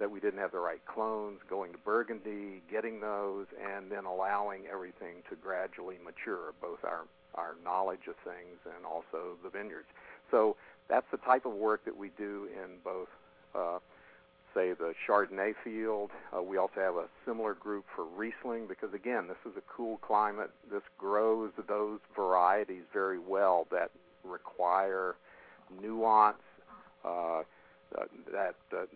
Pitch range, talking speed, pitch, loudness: 95-110 Hz, 150 wpm, 105 Hz, -35 LUFS